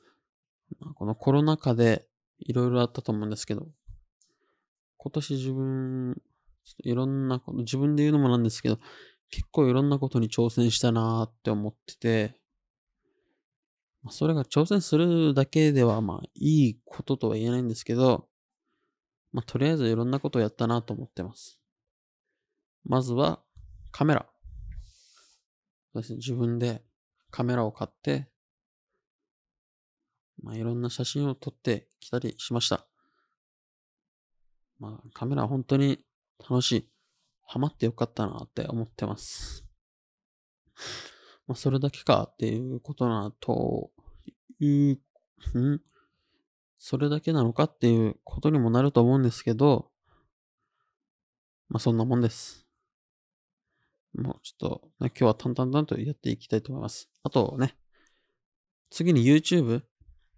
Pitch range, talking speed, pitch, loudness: 115-140 Hz, 265 characters per minute, 125 Hz, -27 LUFS